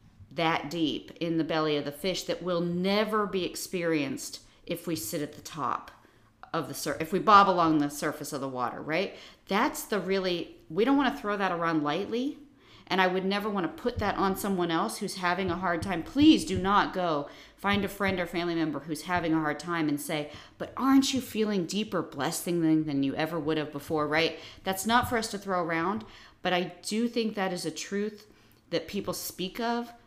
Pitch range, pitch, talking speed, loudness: 155-200 Hz, 175 Hz, 210 wpm, -29 LUFS